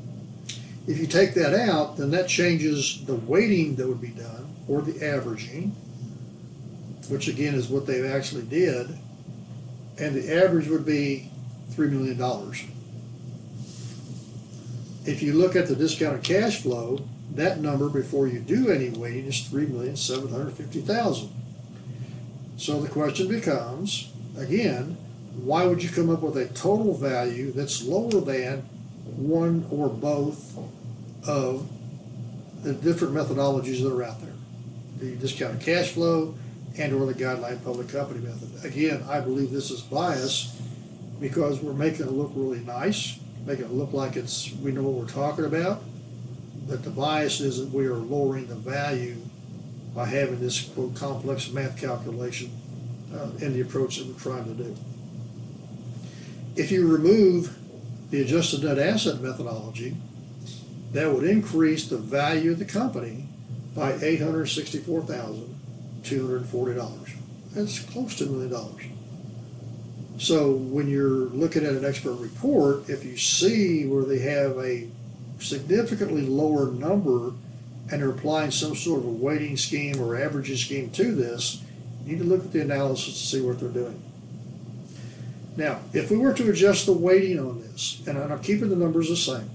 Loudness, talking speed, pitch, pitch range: -26 LUFS, 150 wpm, 135 Hz, 125-155 Hz